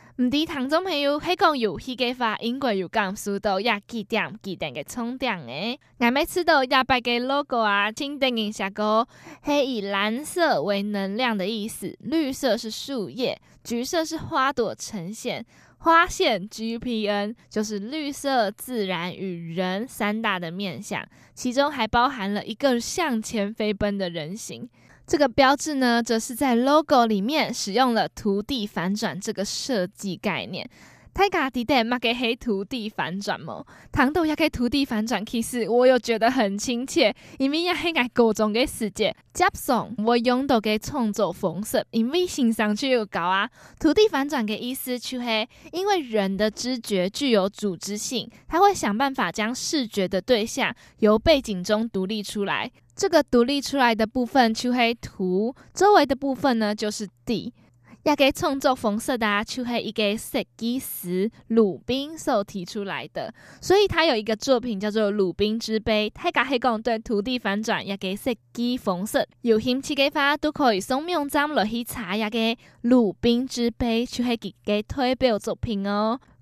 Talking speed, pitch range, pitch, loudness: 260 characters per minute, 210-265 Hz, 235 Hz, -24 LUFS